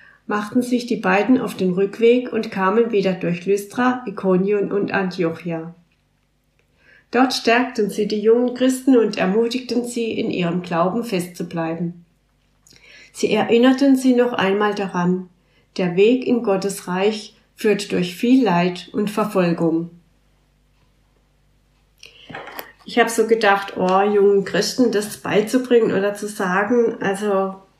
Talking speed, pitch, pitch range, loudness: 125 wpm, 205 Hz, 185-230 Hz, -19 LUFS